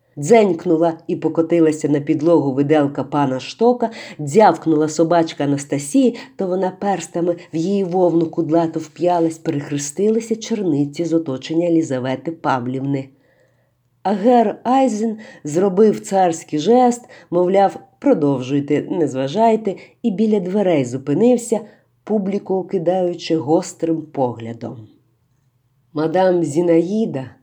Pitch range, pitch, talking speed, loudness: 145-195 Hz, 165 Hz, 95 wpm, -18 LUFS